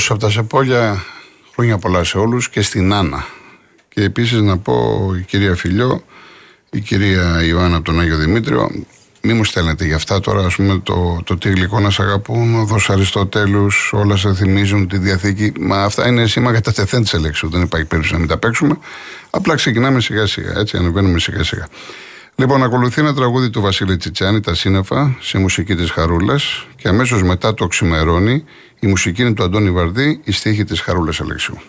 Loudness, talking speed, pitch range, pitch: -15 LUFS, 190 wpm, 90-115 Hz, 100 Hz